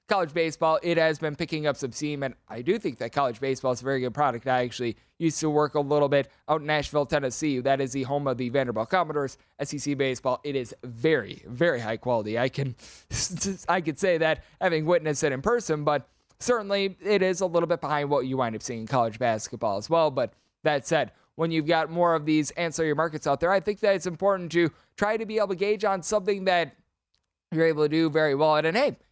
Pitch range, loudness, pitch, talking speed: 135-170 Hz, -26 LUFS, 155 Hz, 235 wpm